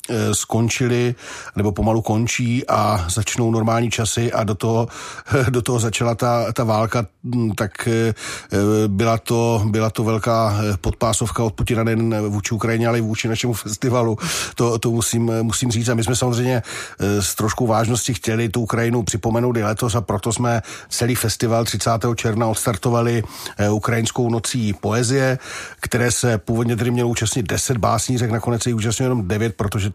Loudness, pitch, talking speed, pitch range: -20 LUFS, 115 Hz, 155 wpm, 110-120 Hz